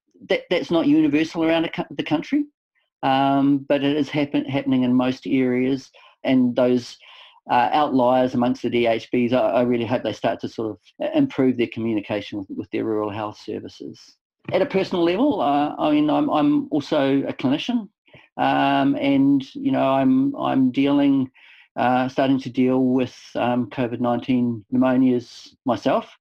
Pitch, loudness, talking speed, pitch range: 135 Hz, -21 LUFS, 160 wpm, 125-180 Hz